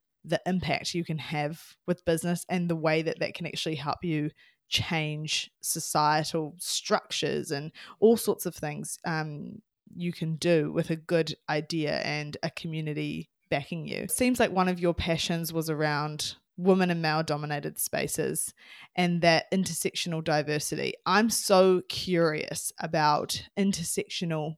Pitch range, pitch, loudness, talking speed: 155-180 Hz, 165 Hz, -28 LUFS, 145 wpm